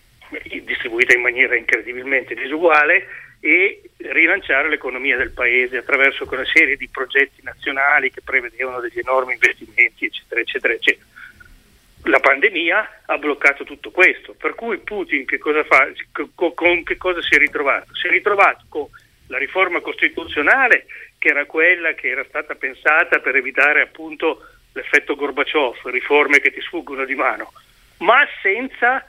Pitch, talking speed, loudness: 185 Hz, 140 wpm, -16 LUFS